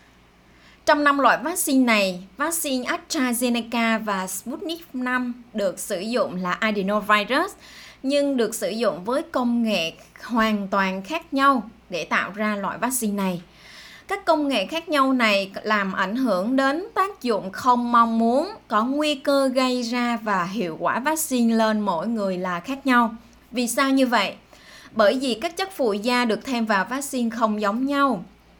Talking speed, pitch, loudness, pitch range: 165 wpm, 240 Hz, -22 LUFS, 210-275 Hz